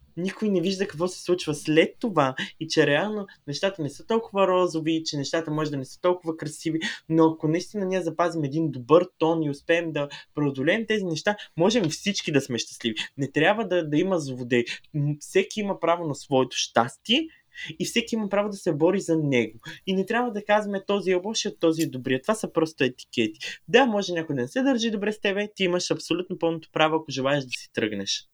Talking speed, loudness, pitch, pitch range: 210 wpm, -25 LUFS, 165 Hz, 150-195 Hz